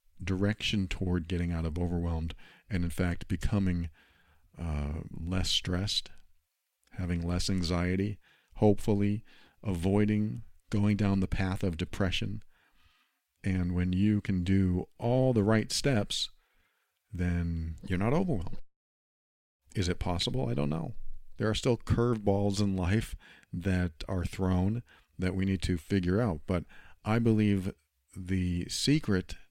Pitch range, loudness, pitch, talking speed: 85-105 Hz, -31 LUFS, 95 Hz, 130 wpm